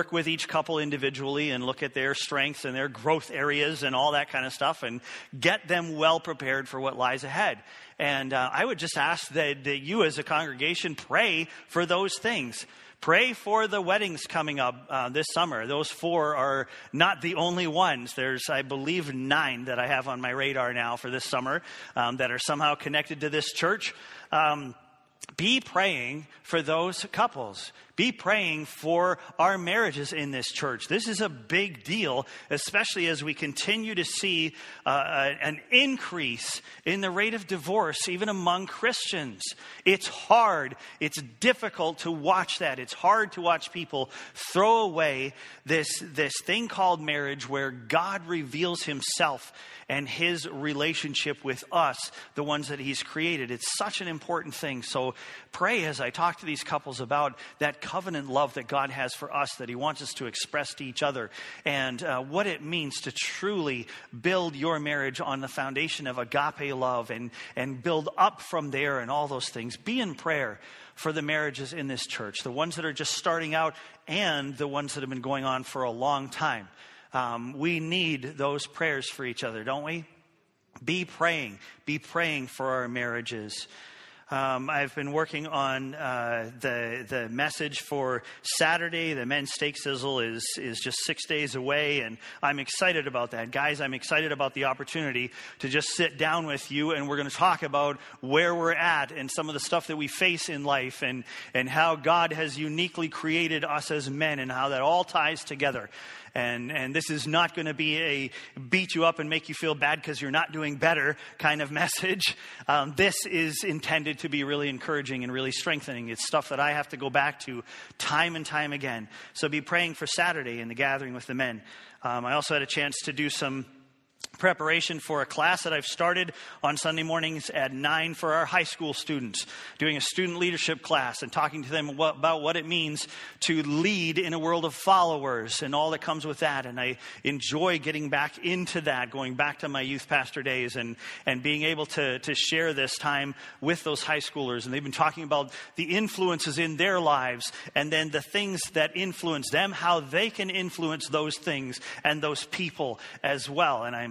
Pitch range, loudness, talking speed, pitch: 135-165 Hz, -28 LUFS, 195 wpm, 150 Hz